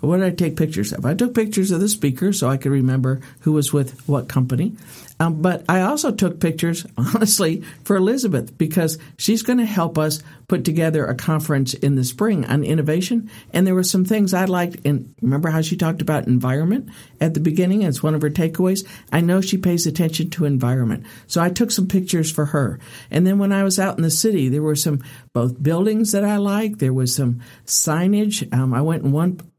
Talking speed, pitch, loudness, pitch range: 215 wpm, 165 Hz, -19 LUFS, 140-190 Hz